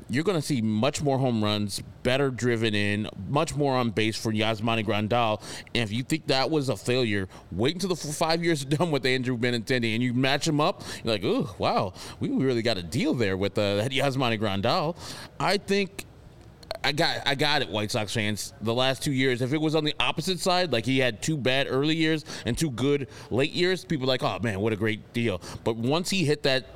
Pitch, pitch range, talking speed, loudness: 130 Hz, 115-150 Hz, 230 wpm, -26 LUFS